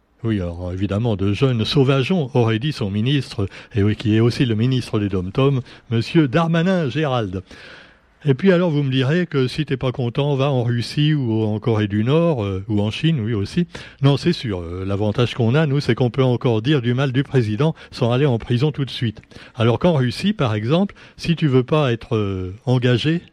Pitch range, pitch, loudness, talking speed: 110-150 Hz, 125 Hz, -19 LUFS, 215 wpm